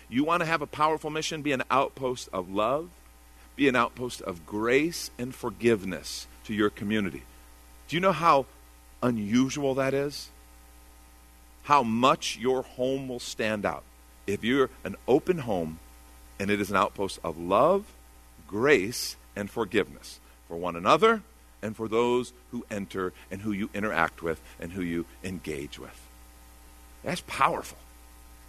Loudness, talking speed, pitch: -28 LUFS, 150 wpm, 95 Hz